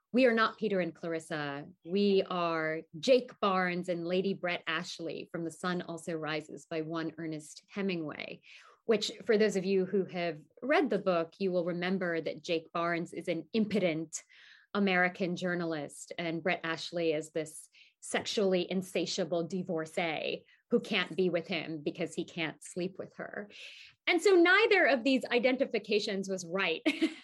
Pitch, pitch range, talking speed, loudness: 180 Hz, 165-200 Hz, 155 wpm, -32 LUFS